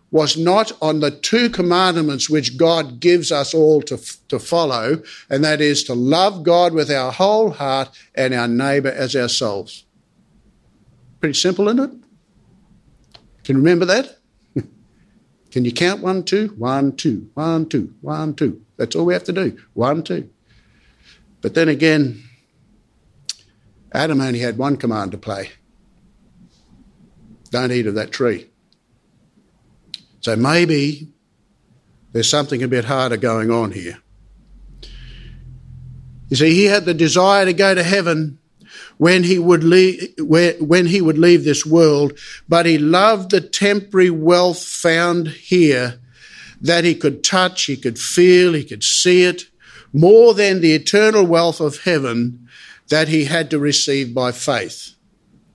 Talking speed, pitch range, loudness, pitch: 145 wpm, 130-175 Hz, -16 LUFS, 155 Hz